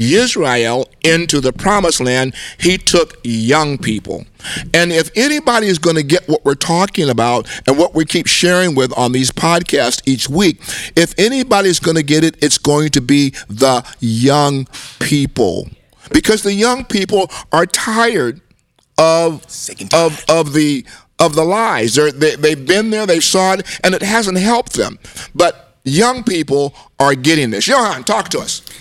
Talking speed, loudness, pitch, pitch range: 165 wpm, -13 LUFS, 160 Hz, 140-185 Hz